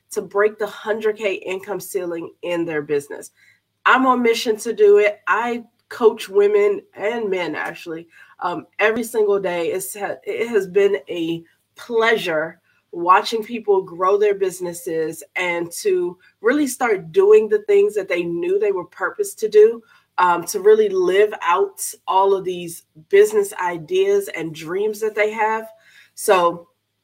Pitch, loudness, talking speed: 210 Hz, -19 LUFS, 150 wpm